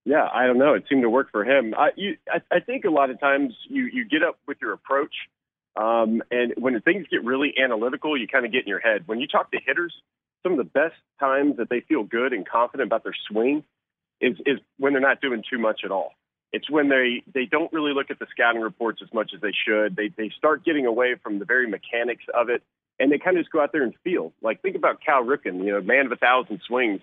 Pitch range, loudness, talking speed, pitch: 110-155 Hz, -23 LUFS, 260 wpm, 130 Hz